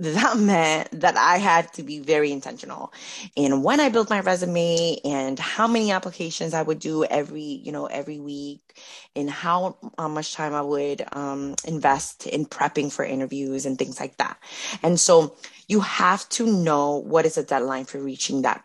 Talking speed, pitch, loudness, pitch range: 180 wpm, 155 Hz, -23 LUFS, 145-175 Hz